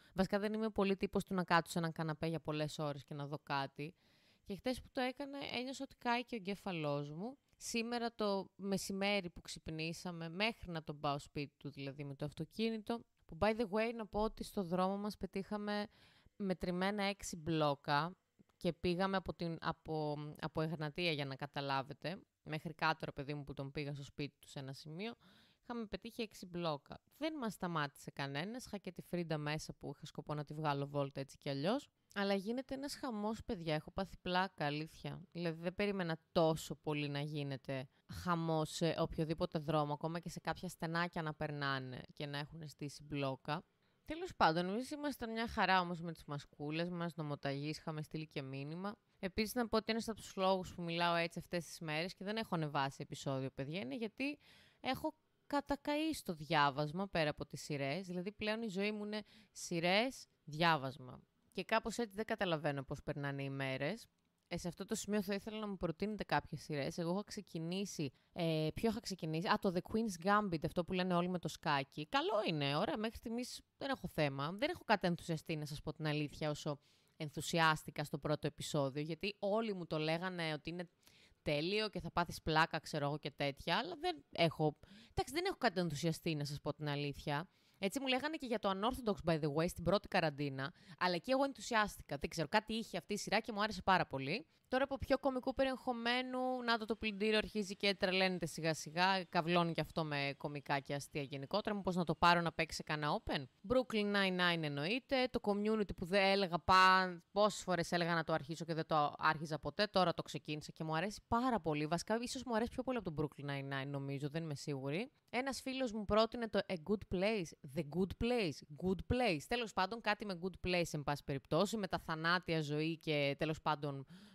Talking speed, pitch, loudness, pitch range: 200 wpm, 175 Hz, -39 LUFS, 150-210 Hz